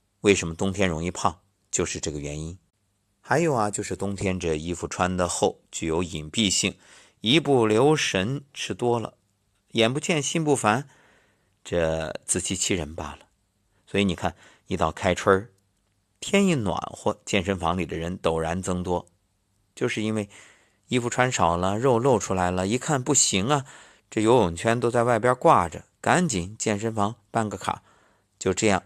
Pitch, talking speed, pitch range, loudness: 100 Hz, 235 characters per minute, 90-115 Hz, -24 LUFS